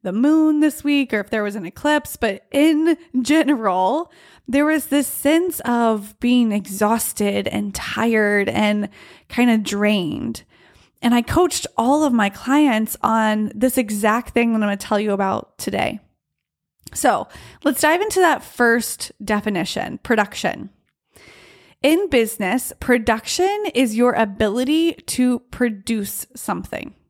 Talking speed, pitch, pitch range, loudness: 135 wpm, 240 Hz, 210-290 Hz, -19 LUFS